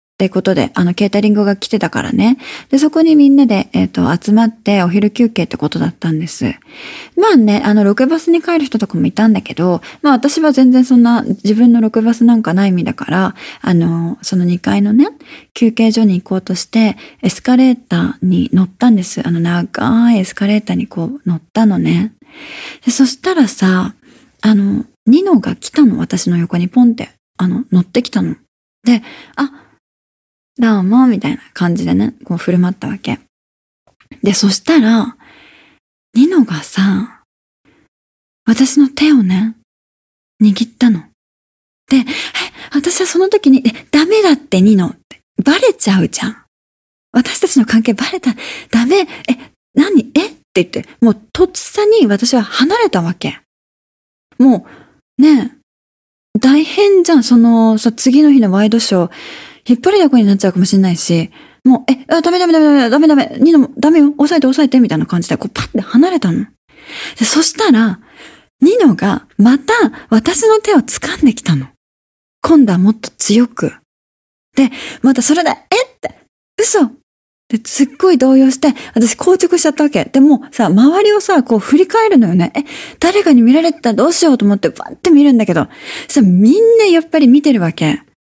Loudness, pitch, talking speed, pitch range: -12 LUFS, 245 Hz, 320 characters per minute, 205-295 Hz